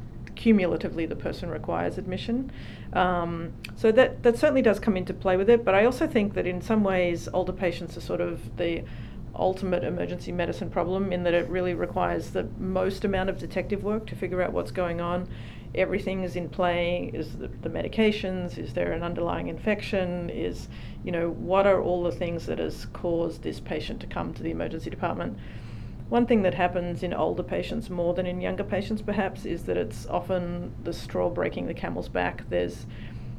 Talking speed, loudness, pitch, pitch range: 190 wpm, -27 LUFS, 180 Hz, 170-195 Hz